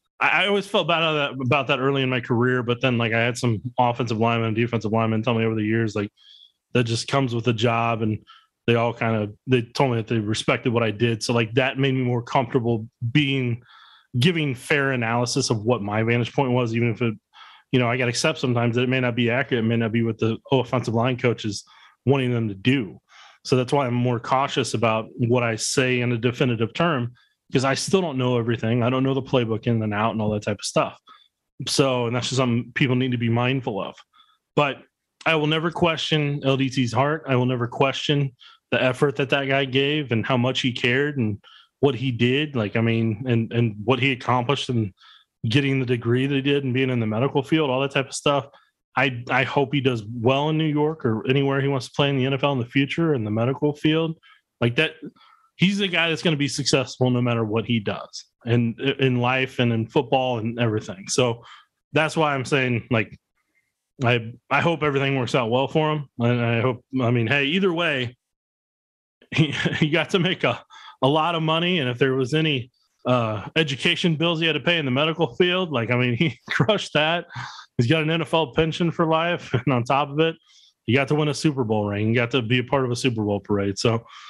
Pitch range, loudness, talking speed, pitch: 120-145 Hz, -22 LUFS, 230 wpm, 130 Hz